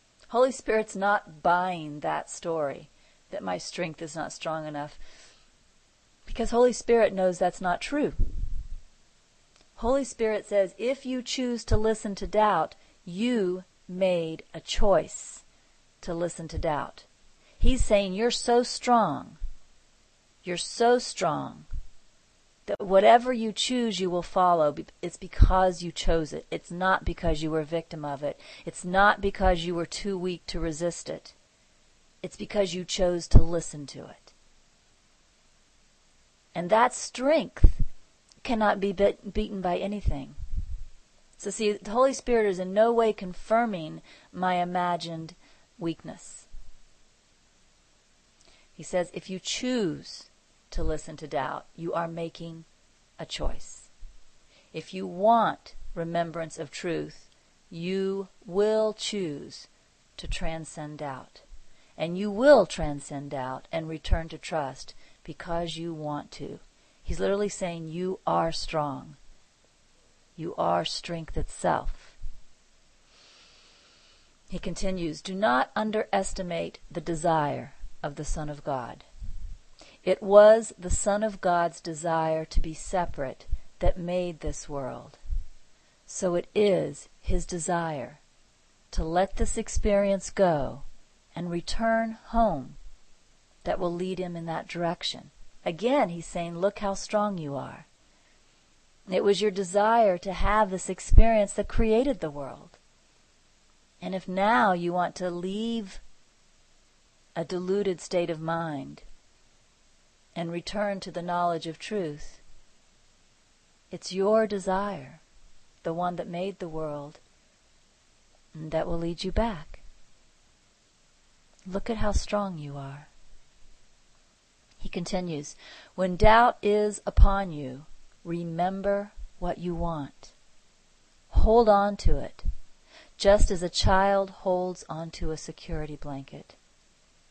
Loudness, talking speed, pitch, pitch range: -28 LUFS, 125 wpm, 180 Hz, 165-205 Hz